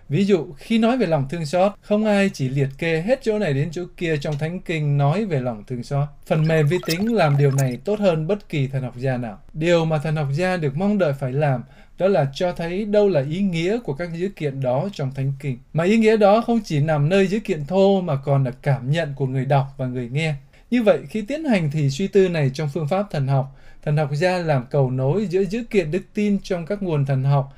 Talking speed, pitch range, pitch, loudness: 260 wpm, 140-195 Hz, 160 Hz, -21 LUFS